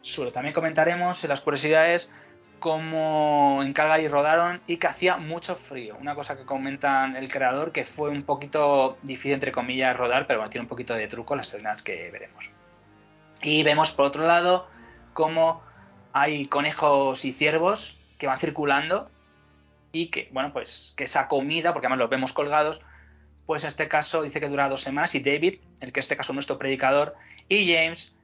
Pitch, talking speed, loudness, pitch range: 145 Hz, 180 wpm, -25 LUFS, 135-160 Hz